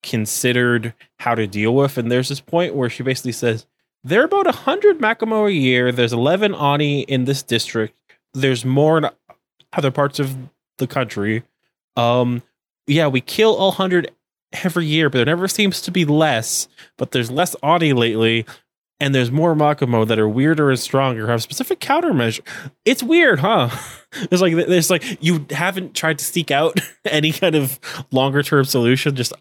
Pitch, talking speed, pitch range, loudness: 140 Hz, 175 wpm, 125-170 Hz, -18 LUFS